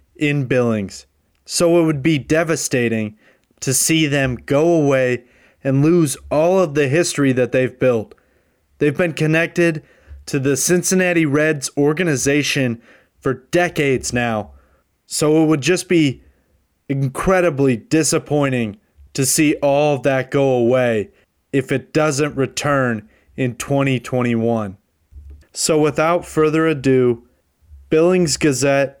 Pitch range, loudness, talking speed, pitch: 120-155 Hz, -17 LUFS, 120 wpm, 140 Hz